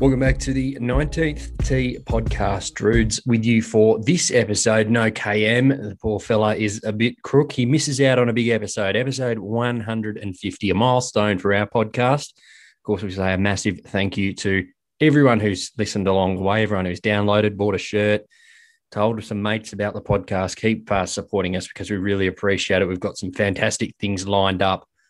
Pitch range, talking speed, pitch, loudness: 100-120 Hz, 195 wpm, 105 Hz, -21 LUFS